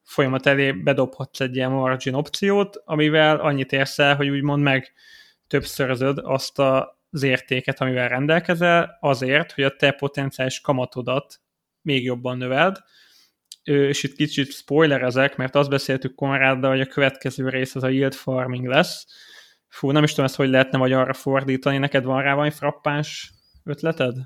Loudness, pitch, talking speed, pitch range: -21 LUFS, 135 Hz, 155 wpm, 130-145 Hz